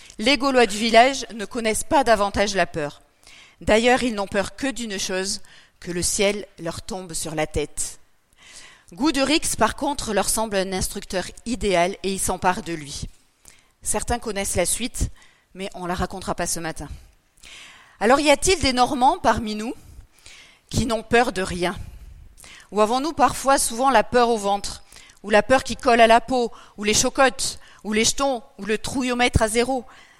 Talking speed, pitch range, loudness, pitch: 175 wpm, 190-245 Hz, -21 LUFS, 215 Hz